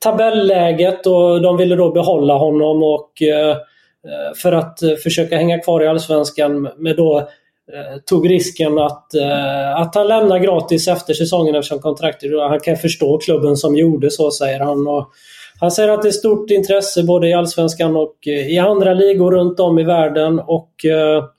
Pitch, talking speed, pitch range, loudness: 165 Hz, 160 wpm, 150-180 Hz, -14 LUFS